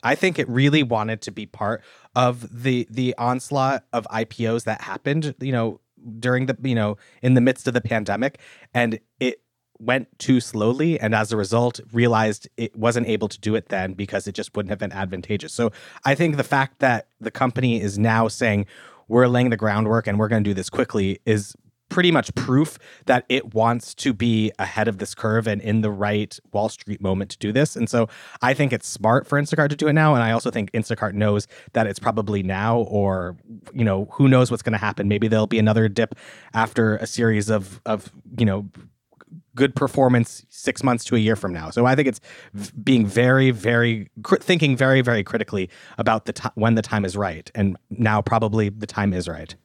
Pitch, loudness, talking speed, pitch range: 115 Hz, -22 LUFS, 215 wpm, 105-125 Hz